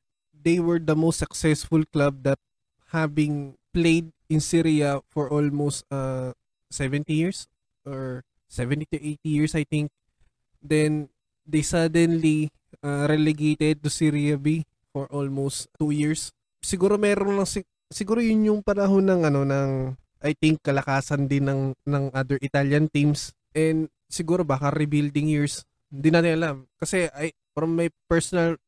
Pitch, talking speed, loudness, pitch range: 150 Hz, 145 wpm, -24 LUFS, 140-165 Hz